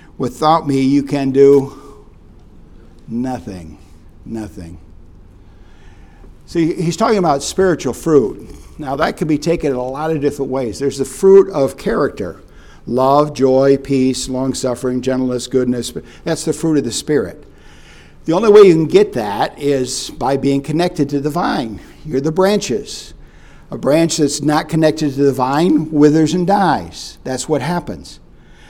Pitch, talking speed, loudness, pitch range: 135 Hz, 155 wpm, -15 LUFS, 115-155 Hz